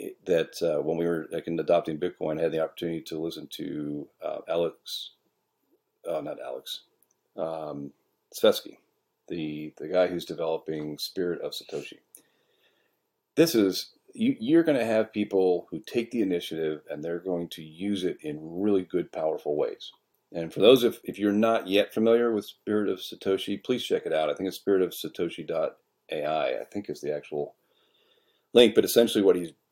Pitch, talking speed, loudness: 100 Hz, 170 wpm, -27 LUFS